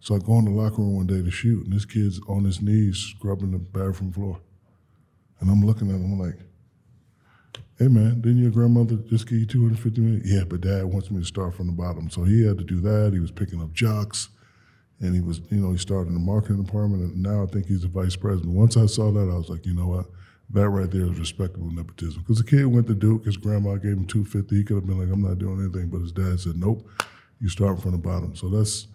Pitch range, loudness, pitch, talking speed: 90-110 Hz, -24 LUFS, 100 Hz, 265 wpm